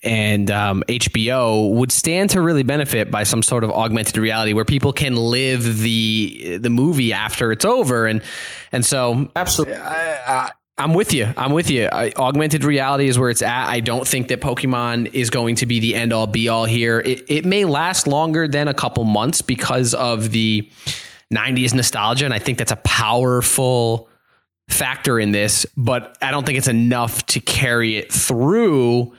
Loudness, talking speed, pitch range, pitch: -18 LUFS, 185 wpm, 115-135 Hz, 120 Hz